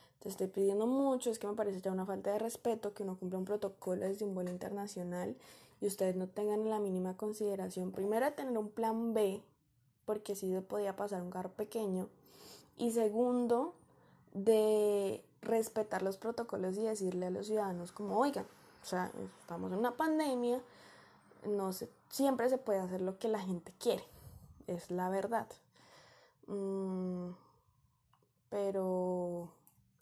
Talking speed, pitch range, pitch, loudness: 155 wpm, 185-220 Hz, 200 Hz, -37 LUFS